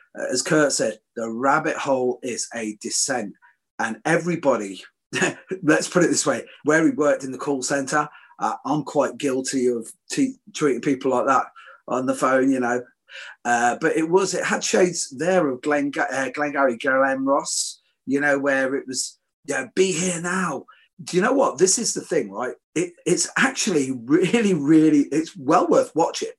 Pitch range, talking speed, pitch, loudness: 130-180 Hz, 185 wpm, 145 Hz, -22 LUFS